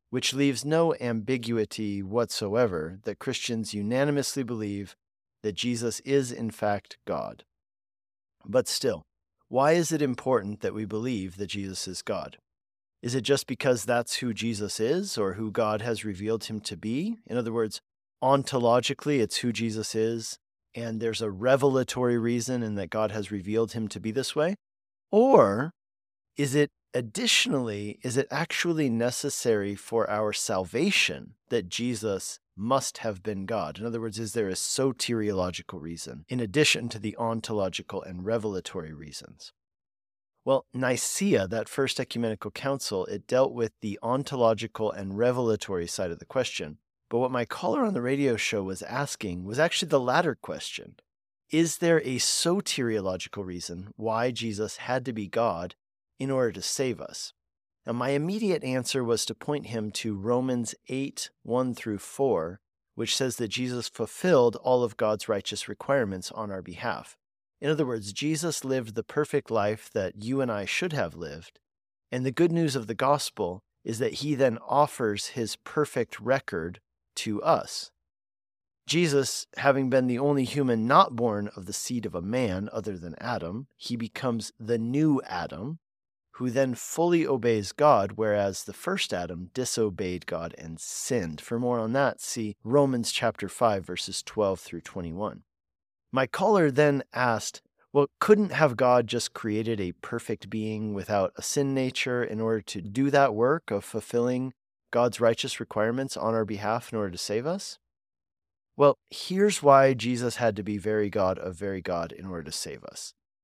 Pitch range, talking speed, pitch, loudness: 105-130 Hz, 165 wpm, 115 Hz, -28 LUFS